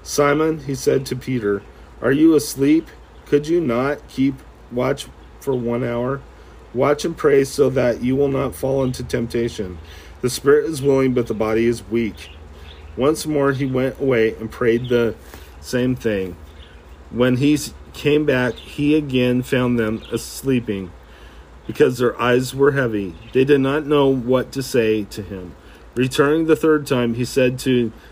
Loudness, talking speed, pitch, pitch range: -19 LUFS, 160 wpm, 125 Hz, 110-140 Hz